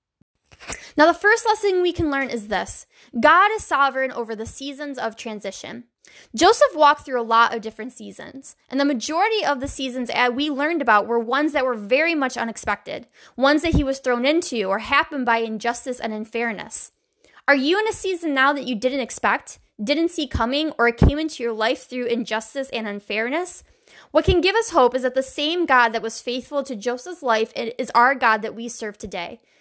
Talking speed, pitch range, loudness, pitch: 200 wpm, 230-300 Hz, -21 LUFS, 260 Hz